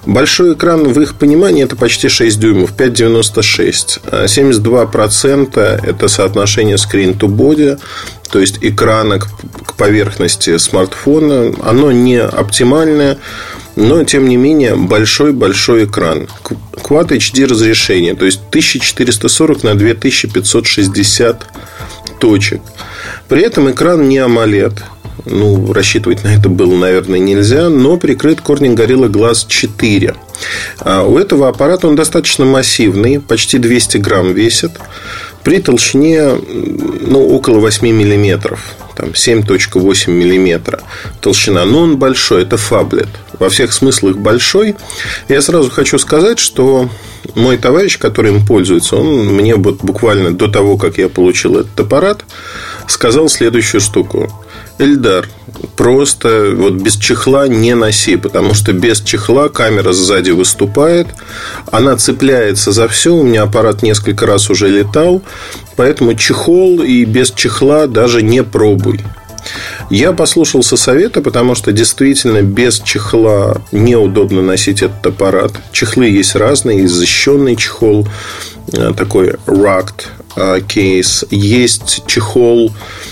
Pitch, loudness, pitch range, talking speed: 110 Hz, -9 LUFS, 100-135 Hz, 120 wpm